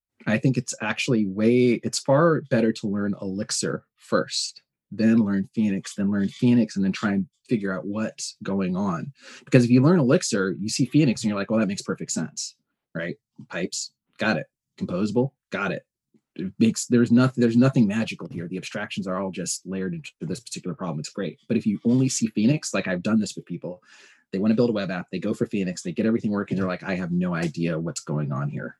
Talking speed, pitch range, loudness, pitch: 225 wpm, 100-125 Hz, -24 LUFS, 110 Hz